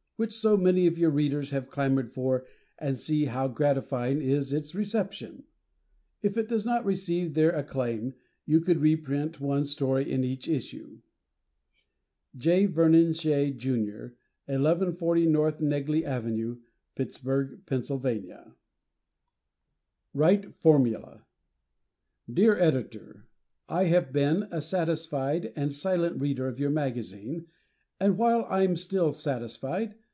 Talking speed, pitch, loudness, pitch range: 120 wpm, 145 Hz, -28 LUFS, 130-170 Hz